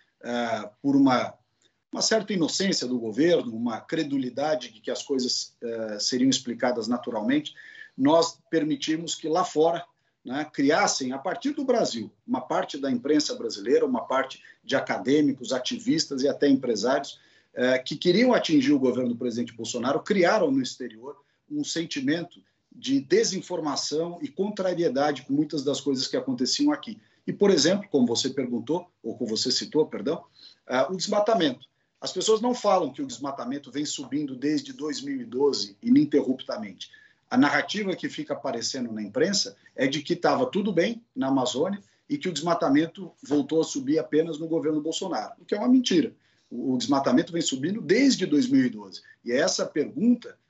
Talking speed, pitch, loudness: 160 wpm, 165 Hz, -26 LUFS